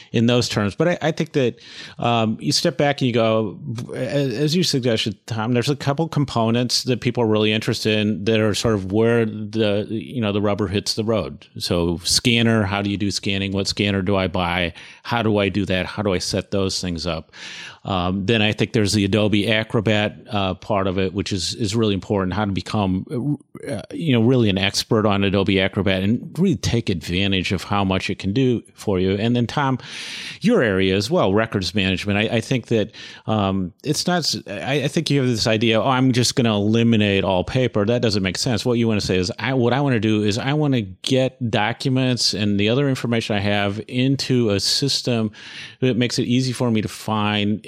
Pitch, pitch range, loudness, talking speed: 110 Hz, 100-125 Hz, -20 LUFS, 225 wpm